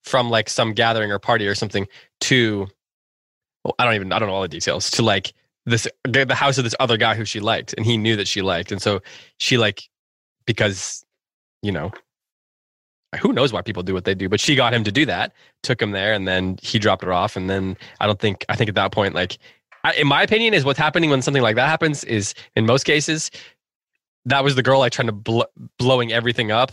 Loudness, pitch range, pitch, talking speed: -19 LUFS, 100-130 Hz, 115 Hz, 240 wpm